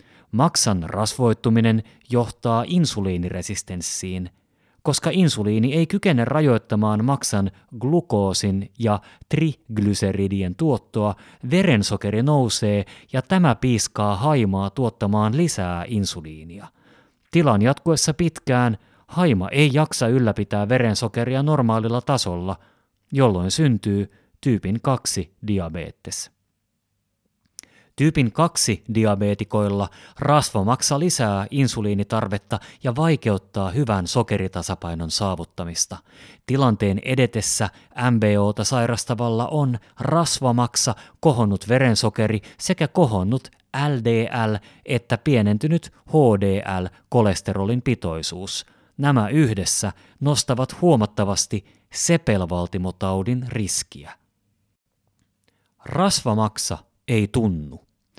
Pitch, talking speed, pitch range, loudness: 110 Hz, 75 wpm, 100-130 Hz, -21 LUFS